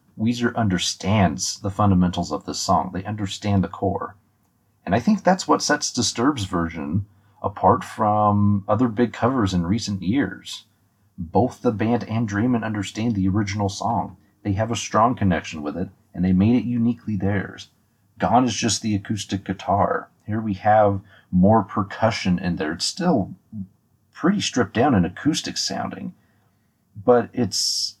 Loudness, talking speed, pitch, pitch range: -22 LUFS, 155 wpm, 105 Hz, 95-115 Hz